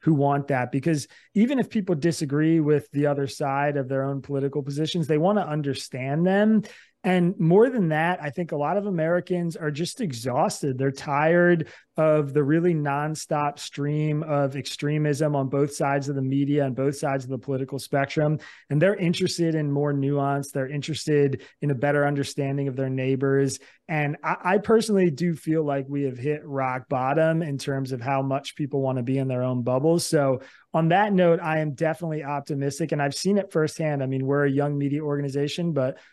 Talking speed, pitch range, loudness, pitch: 195 wpm, 140-160 Hz, -24 LUFS, 145 Hz